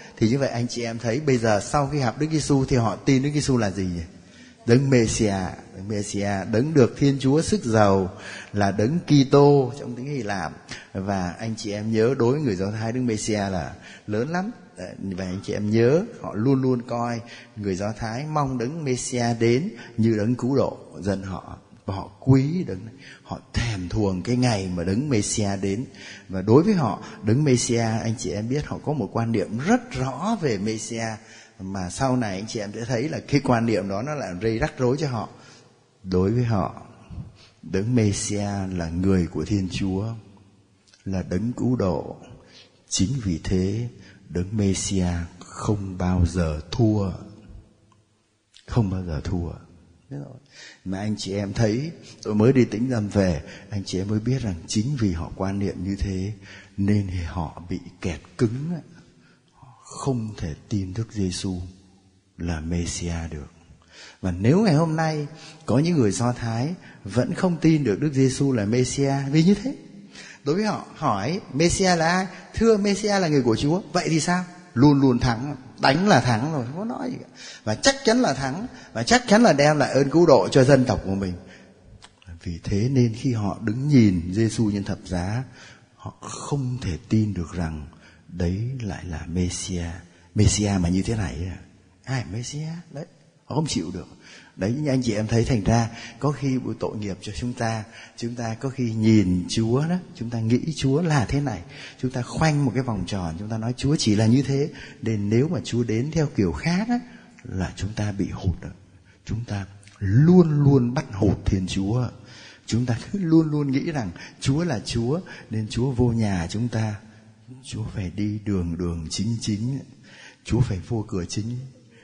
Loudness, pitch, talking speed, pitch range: -23 LUFS, 110 Hz, 190 wpm, 95-135 Hz